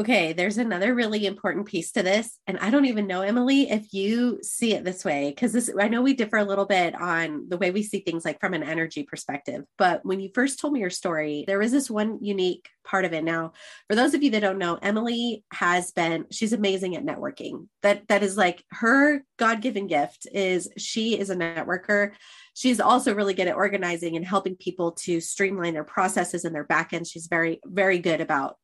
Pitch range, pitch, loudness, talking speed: 175-215 Hz, 195 Hz, -25 LUFS, 215 wpm